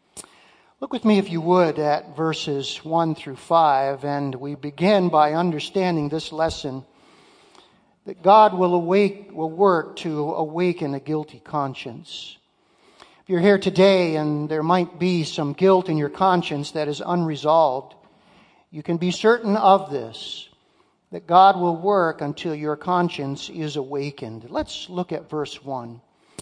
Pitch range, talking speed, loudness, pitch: 150-185 Hz, 150 wpm, -21 LUFS, 160 Hz